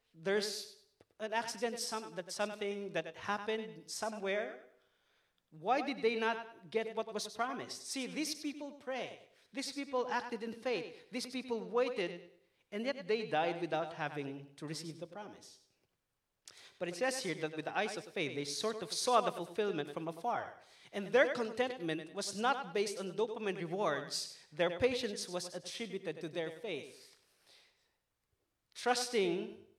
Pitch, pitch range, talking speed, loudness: 210 Hz, 175-240 Hz, 150 wpm, -37 LUFS